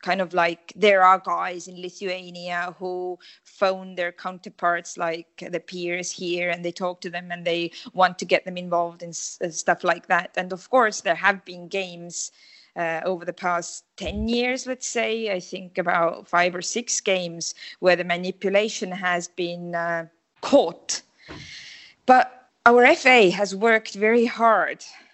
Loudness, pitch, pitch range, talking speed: -23 LUFS, 180 Hz, 175-205 Hz, 165 wpm